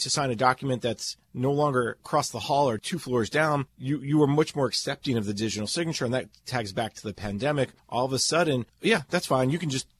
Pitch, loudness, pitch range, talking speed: 130 Hz, -27 LUFS, 120-150 Hz, 245 wpm